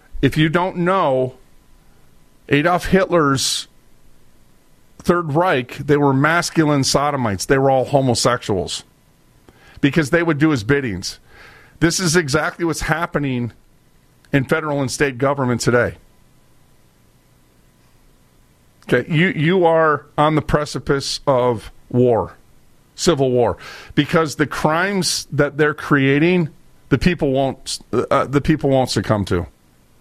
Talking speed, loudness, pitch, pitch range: 120 wpm, -18 LUFS, 145 Hz, 130-160 Hz